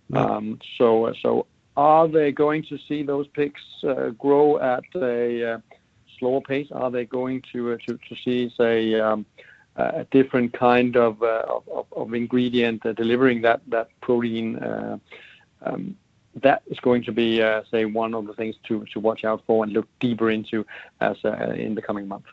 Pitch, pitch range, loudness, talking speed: 120 Hz, 115-130 Hz, -23 LUFS, 185 wpm